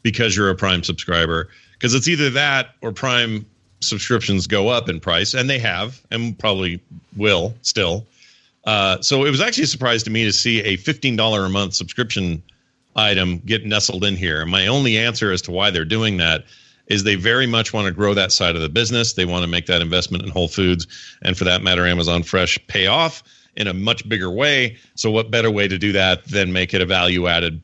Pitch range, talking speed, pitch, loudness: 90-115 Hz, 220 wpm, 105 Hz, -18 LUFS